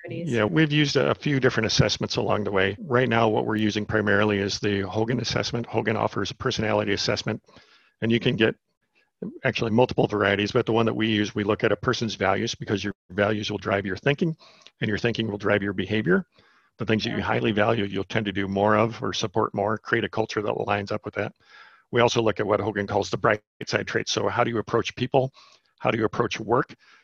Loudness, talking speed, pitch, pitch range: -24 LUFS, 230 wpm, 110 Hz, 105-120 Hz